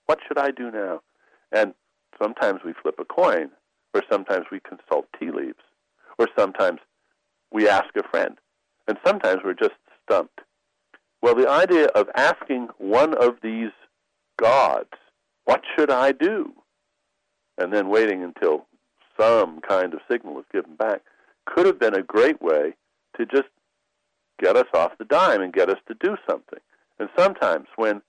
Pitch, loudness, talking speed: 365 Hz, -22 LUFS, 160 wpm